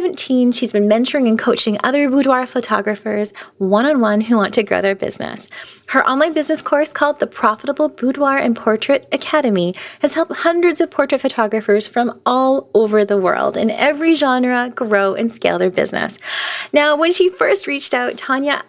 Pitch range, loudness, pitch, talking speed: 220-295 Hz, -16 LUFS, 255 Hz, 175 wpm